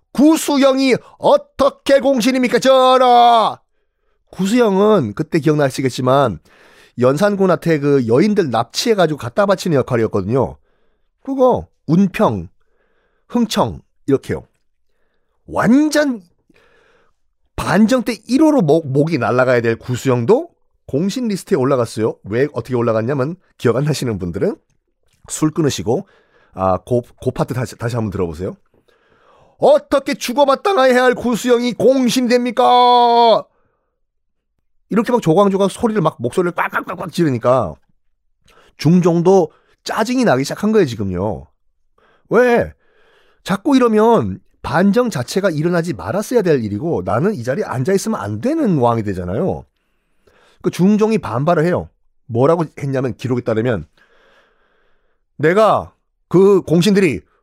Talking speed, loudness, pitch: 280 characters per minute, -16 LUFS, 195 Hz